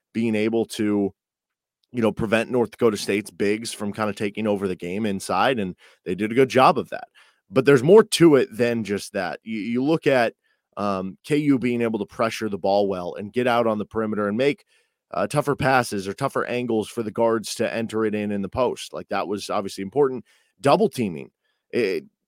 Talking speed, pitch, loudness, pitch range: 215 wpm, 110 Hz, -22 LUFS, 105-130 Hz